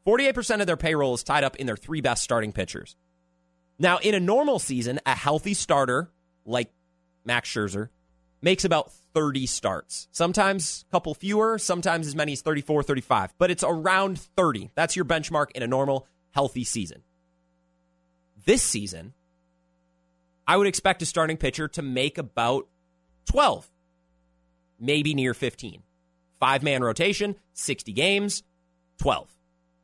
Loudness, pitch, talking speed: -25 LUFS, 130 Hz, 145 wpm